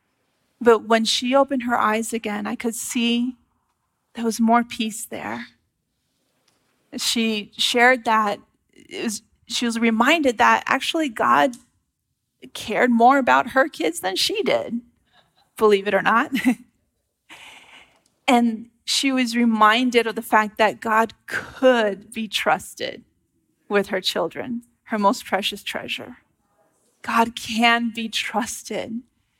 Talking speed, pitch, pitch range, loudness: 125 wpm, 235 Hz, 220-245 Hz, -20 LUFS